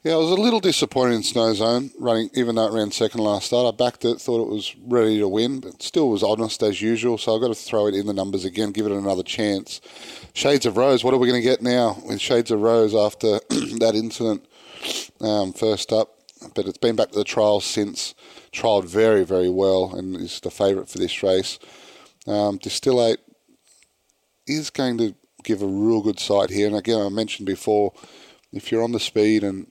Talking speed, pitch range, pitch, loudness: 215 wpm, 105-120 Hz, 110 Hz, -21 LUFS